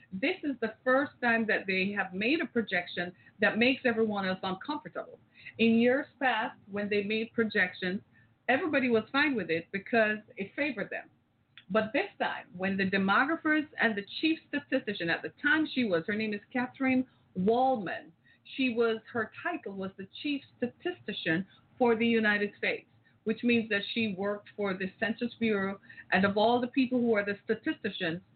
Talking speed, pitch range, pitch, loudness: 175 wpm, 195-255 Hz, 220 Hz, -30 LUFS